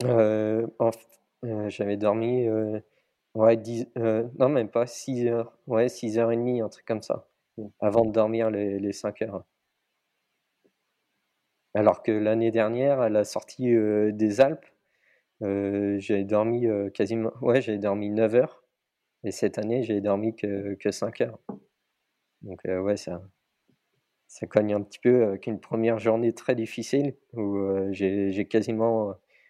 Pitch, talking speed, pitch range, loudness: 110 Hz, 160 wpm, 100-115 Hz, -26 LUFS